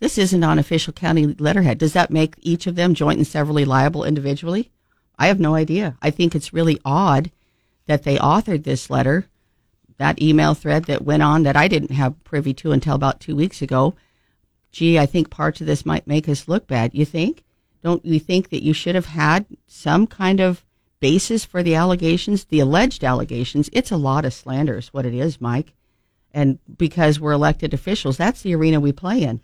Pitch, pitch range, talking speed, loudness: 155 Hz, 140-175 Hz, 205 wpm, -19 LUFS